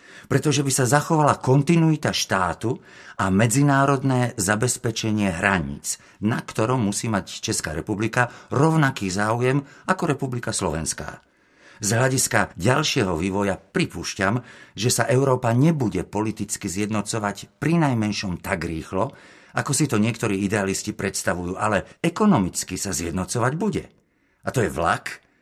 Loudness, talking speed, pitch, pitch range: -22 LUFS, 120 wpm, 115 Hz, 100-140 Hz